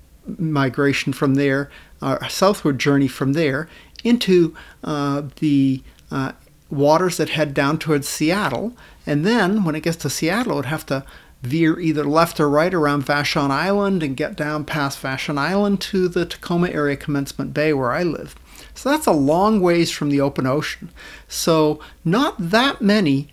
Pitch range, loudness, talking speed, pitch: 140-175 Hz, -19 LUFS, 165 wpm, 155 Hz